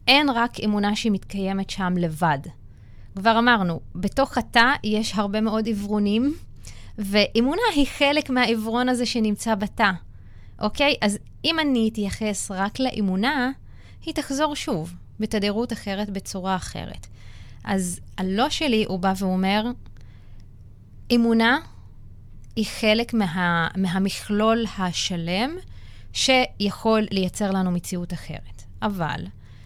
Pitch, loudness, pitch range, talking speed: 205 Hz, -23 LUFS, 175-230 Hz, 105 wpm